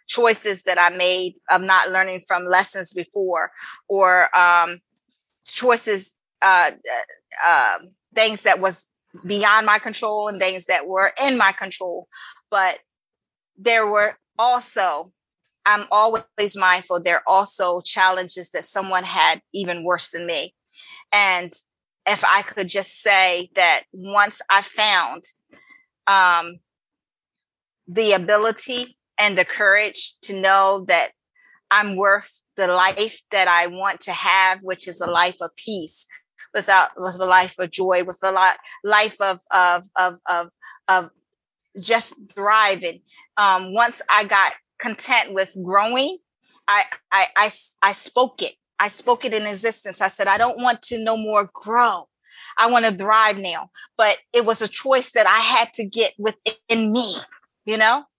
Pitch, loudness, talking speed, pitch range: 200 Hz, -18 LUFS, 150 wpm, 185-225 Hz